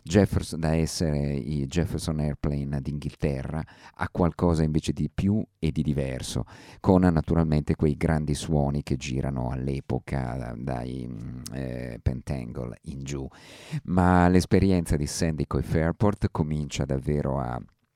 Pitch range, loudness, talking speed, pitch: 70-85 Hz, -27 LUFS, 125 wpm, 75 Hz